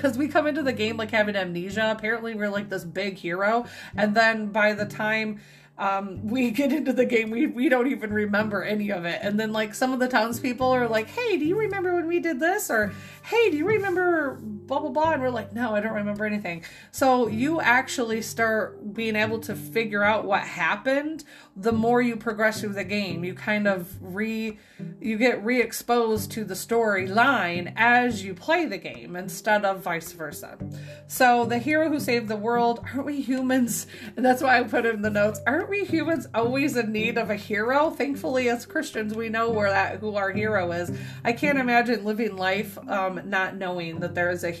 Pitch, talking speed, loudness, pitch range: 225 Hz, 210 wpm, -25 LUFS, 205-255 Hz